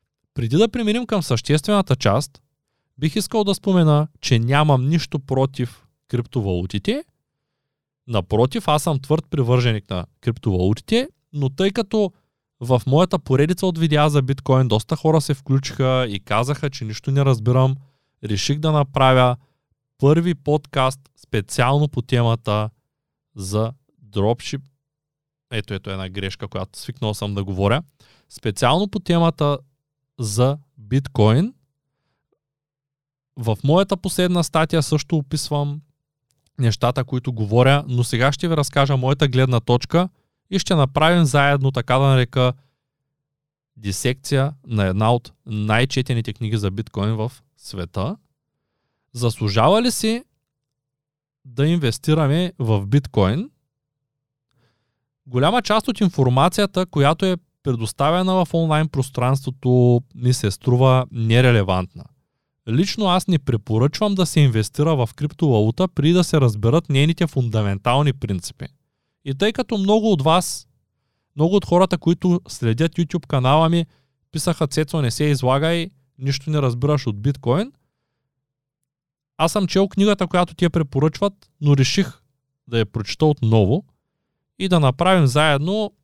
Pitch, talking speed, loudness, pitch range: 140 Hz, 125 wpm, -19 LUFS, 125-155 Hz